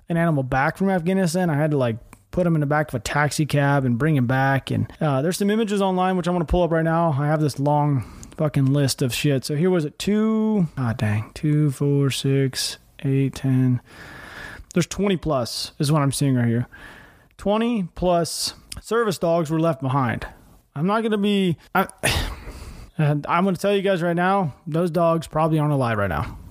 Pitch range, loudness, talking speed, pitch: 135-180 Hz, -22 LUFS, 210 wpm, 155 Hz